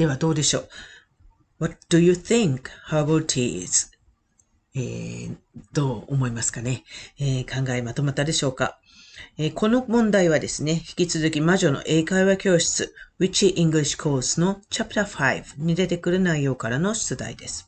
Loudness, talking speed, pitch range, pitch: -23 LUFS, 335 characters per minute, 130-175 Hz, 155 Hz